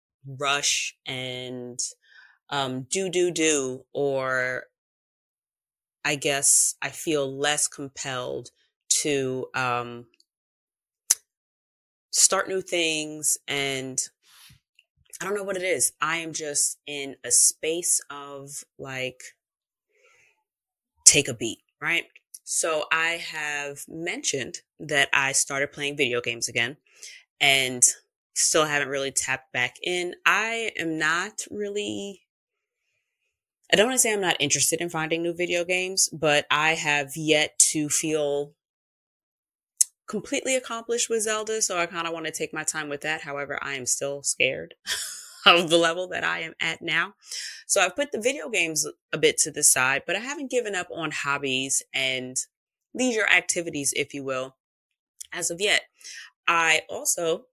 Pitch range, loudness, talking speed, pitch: 135-180 Hz, -24 LUFS, 140 wpm, 155 Hz